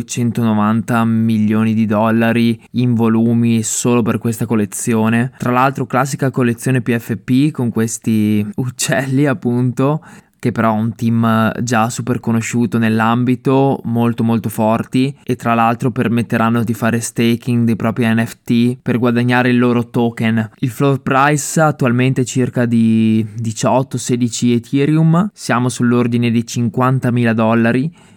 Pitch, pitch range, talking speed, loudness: 120 Hz, 115-125 Hz, 130 wpm, -15 LUFS